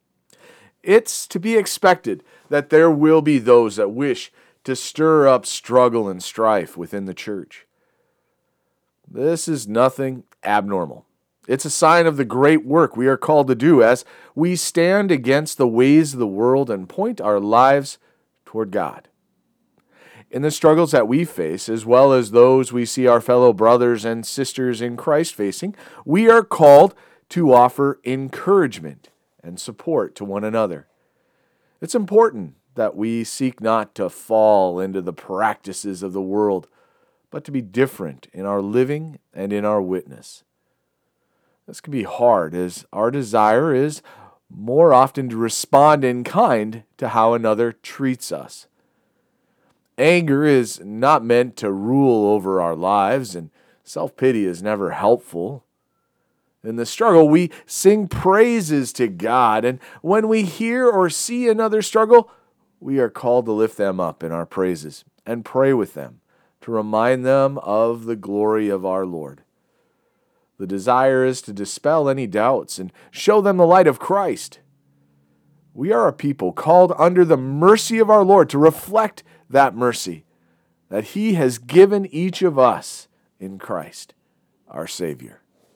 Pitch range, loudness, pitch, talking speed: 105-160 Hz, -17 LUFS, 130 Hz, 155 wpm